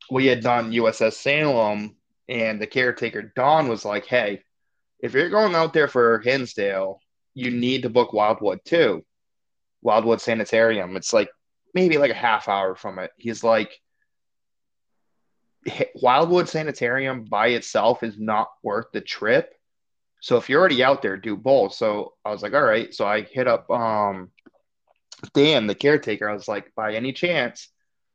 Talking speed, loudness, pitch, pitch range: 160 wpm, -21 LUFS, 115 Hz, 105-135 Hz